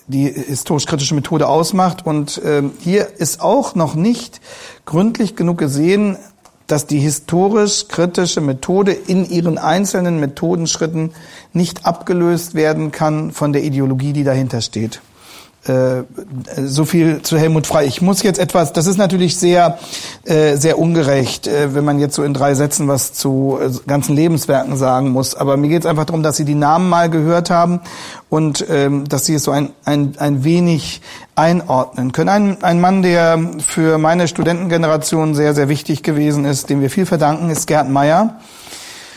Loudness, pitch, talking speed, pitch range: -15 LUFS, 155 Hz, 160 wpm, 145-175 Hz